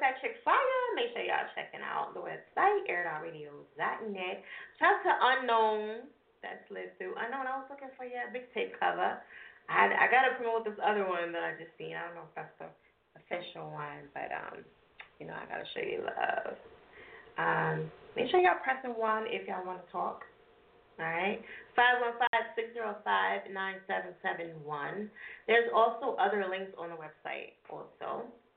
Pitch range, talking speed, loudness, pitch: 185-260 Hz, 180 wpm, -32 LUFS, 220 Hz